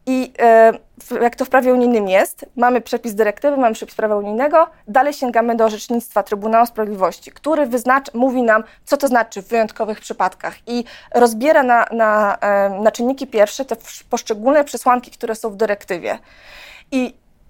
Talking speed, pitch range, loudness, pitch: 155 wpm, 220-260 Hz, -17 LUFS, 235 Hz